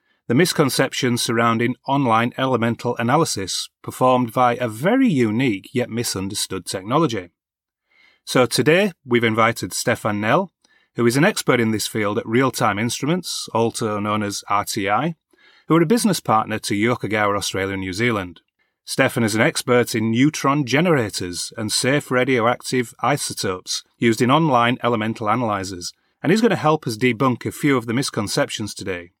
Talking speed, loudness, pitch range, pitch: 150 wpm, -20 LUFS, 110-135 Hz, 120 Hz